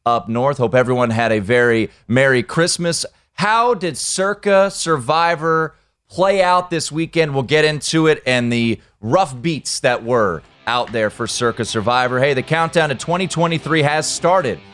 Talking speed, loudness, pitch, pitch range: 160 wpm, -17 LUFS, 155 Hz, 120-170 Hz